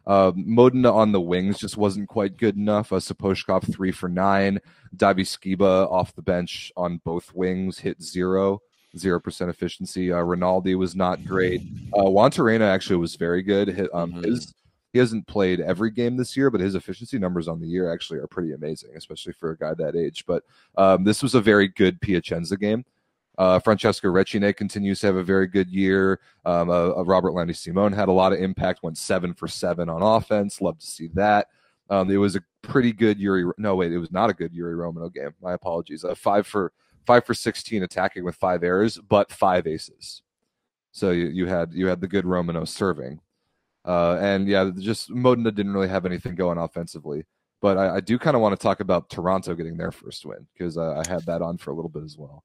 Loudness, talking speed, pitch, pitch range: -23 LUFS, 210 wpm, 95 Hz, 90-100 Hz